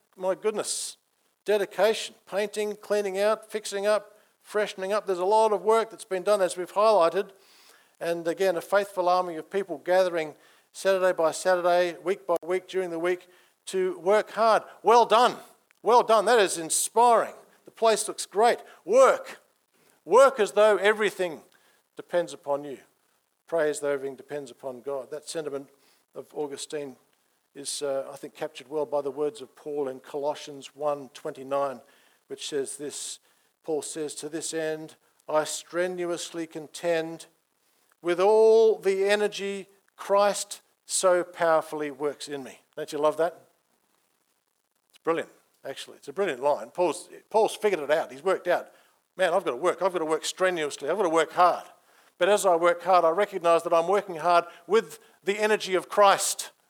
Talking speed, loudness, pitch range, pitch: 165 wpm, -26 LUFS, 155-205 Hz, 180 Hz